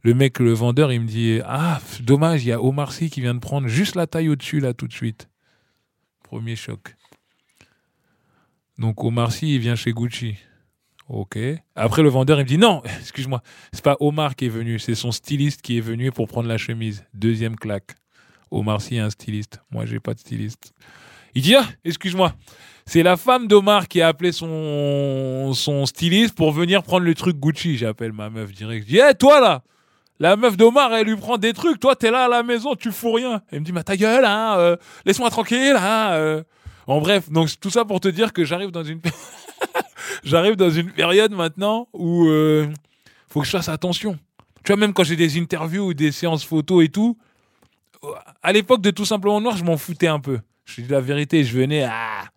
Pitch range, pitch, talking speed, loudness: 120-195 Hz, 155 Hz, 215 wpm, -19 LUFS